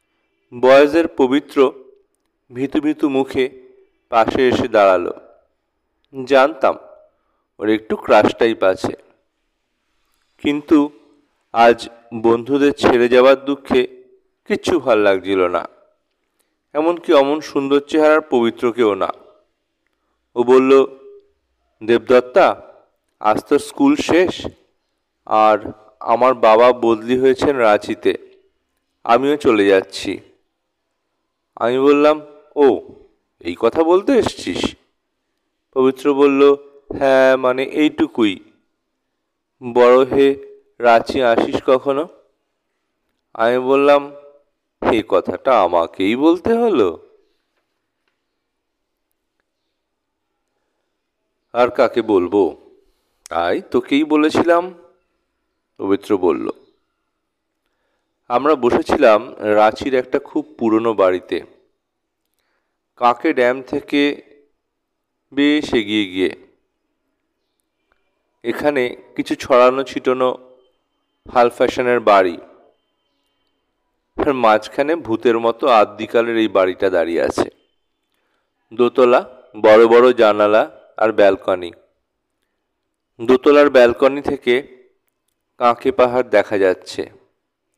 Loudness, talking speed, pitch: -16 LUFS, 80 wpm, 145 Hz